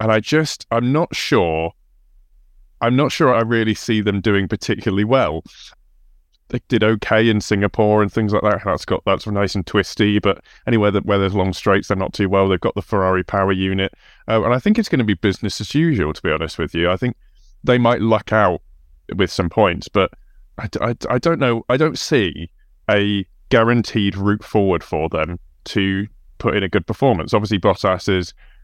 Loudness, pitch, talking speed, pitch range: -18 LUFS, 105 Hz, 205 wpm, 95-115 Hz